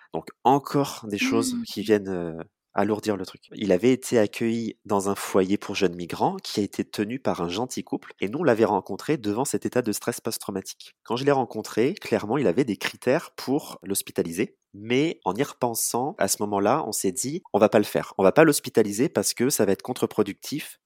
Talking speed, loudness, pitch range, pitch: 215 wpm, -25 LUFS, 100-125 Hz, 105 Hz